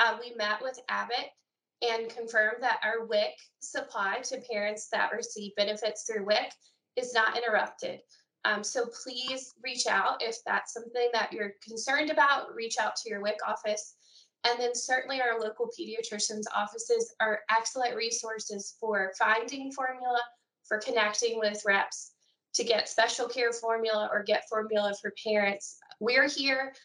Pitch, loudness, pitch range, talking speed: 225 Hz, -30 LUFS, 215-250 Hz, 150 wpm